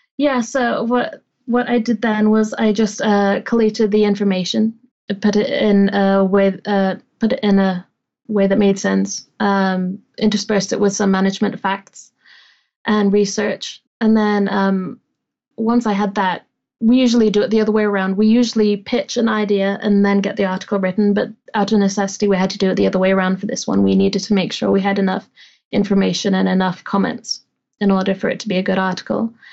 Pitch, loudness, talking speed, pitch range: 205 Hz, -17 LUFS, 205 wpm, 195-220 Hz